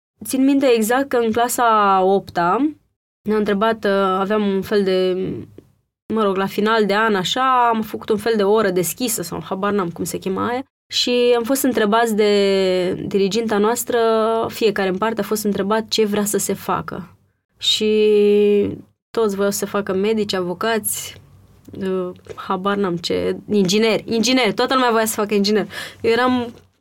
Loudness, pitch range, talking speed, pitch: -18 LUFS, 195-225 Hz, 165 wpm, 210 Hz